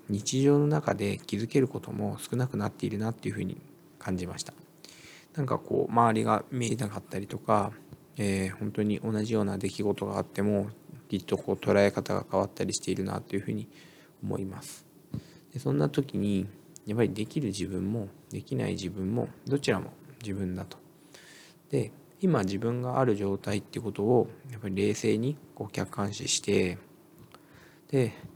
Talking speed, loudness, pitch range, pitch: 345 characters per minute, -30 LUFS, 100-130 Hz, 105 Hz